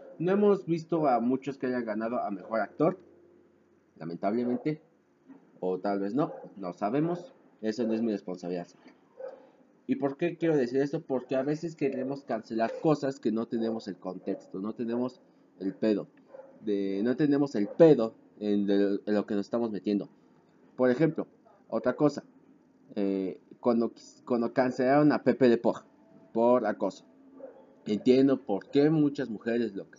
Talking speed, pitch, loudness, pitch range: 150 wpm, 120 Hz, -29 LUFS, 105-145 Hz